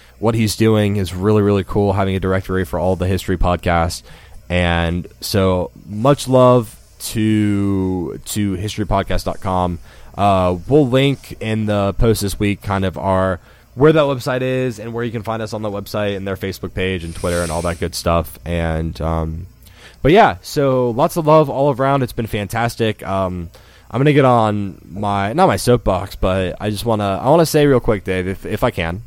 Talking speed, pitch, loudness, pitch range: 200 wpm, 100 Hz, -17 LUFS, 90-115 Hz